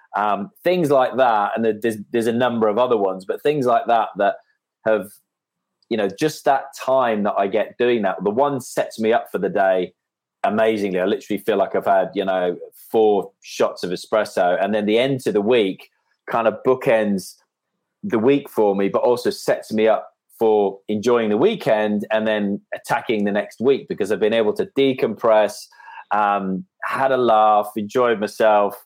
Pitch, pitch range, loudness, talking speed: 110 Hz, 105-125 Hz, -20 LUFS, 185 wpm